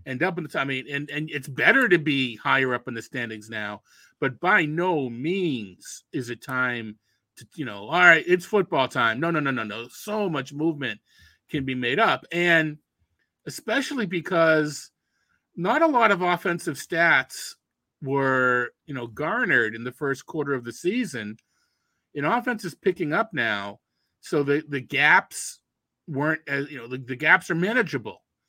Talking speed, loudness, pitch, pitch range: 180 wpm, -24 LUFS, 145 Hz, 130-175 Hz